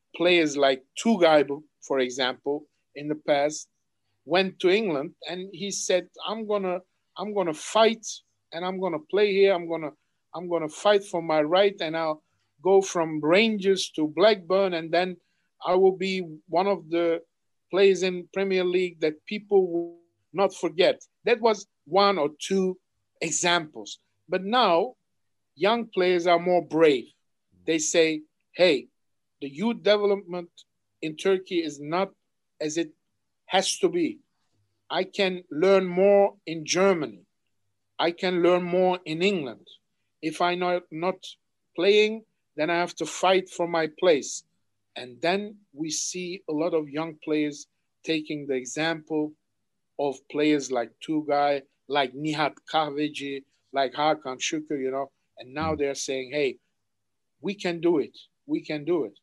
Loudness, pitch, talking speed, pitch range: -25 LUFS, 170 Hz, 150 wpm, 150-190 Hz